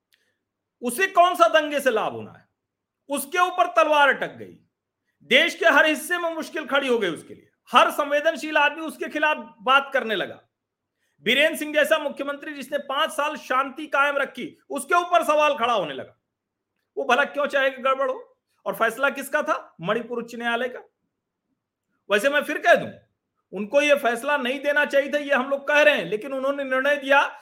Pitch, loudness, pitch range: 290 Hz, -22 LUFS, 275-315 Hz